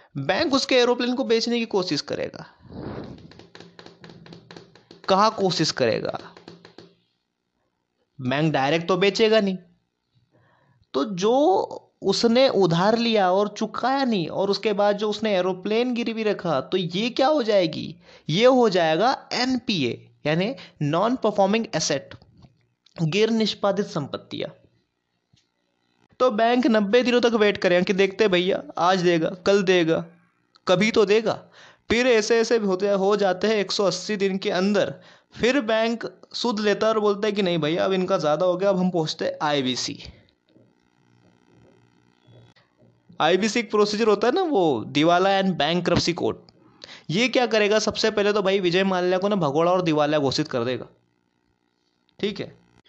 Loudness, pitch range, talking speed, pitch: -22 LUFS, 155-220 Hz, 145 wpm, 190 Hz